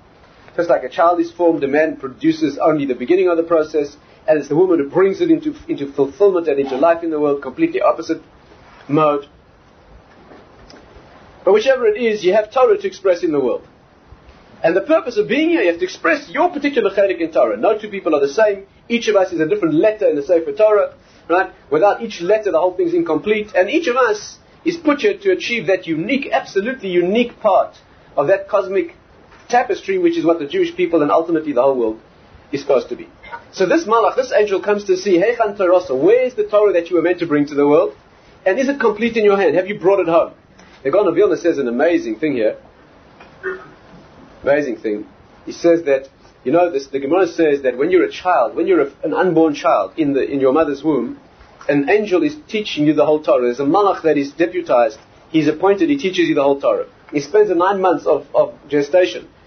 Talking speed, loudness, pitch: 220 wpm, -16 LUFS, 195 Hz